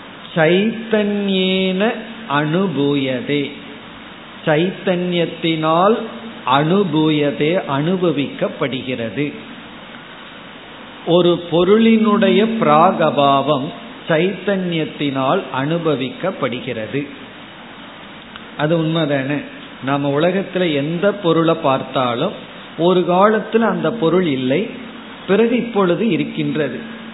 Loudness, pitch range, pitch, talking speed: -17 LUFS, 145-205 Hz, 175 Hz, 55 wpm